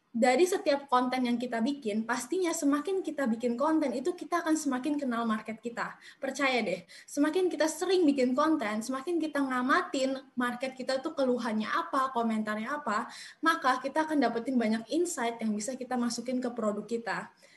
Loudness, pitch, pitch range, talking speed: -30 LUFS, 265 Hz, 235-300 Hz, 165 wpm